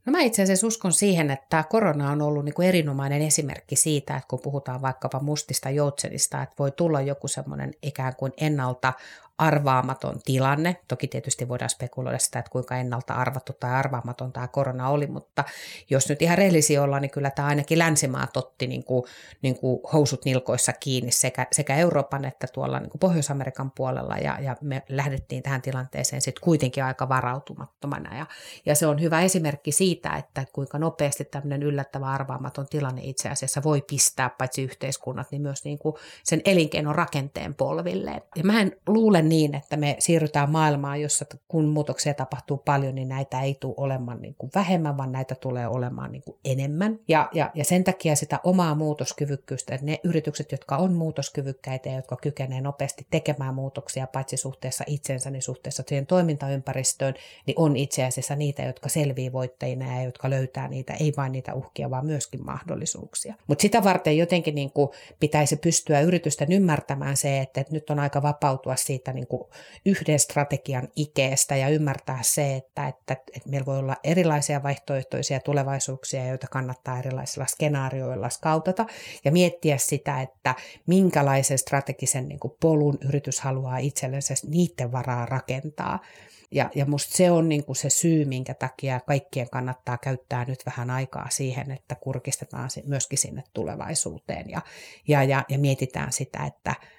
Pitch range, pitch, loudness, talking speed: 130-150 Hz, 140 Hz, -25 LUFS, 165 wpm